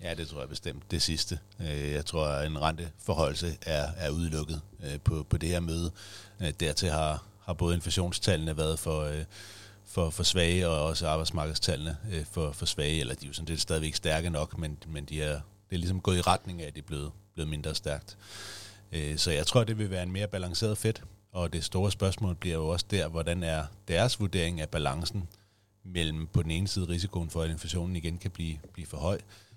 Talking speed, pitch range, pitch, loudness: 205 wpm, 80-95 Hz, 85 Hz, -31 LUFS